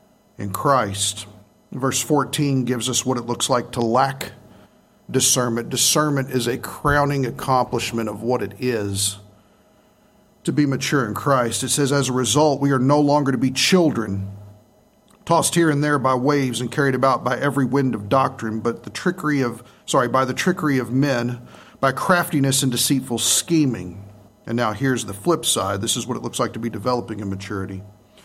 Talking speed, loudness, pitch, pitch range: 180 wpm, -20 LUFS, 130 Hz, 115-145 Hz